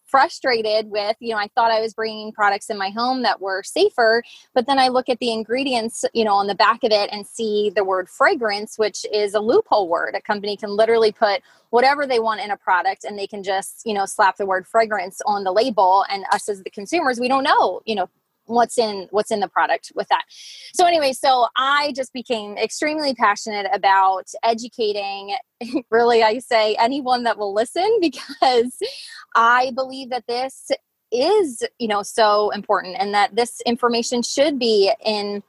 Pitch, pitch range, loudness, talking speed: 230 Hz, 210-260 Hz, -20 LUFS, 195 wpm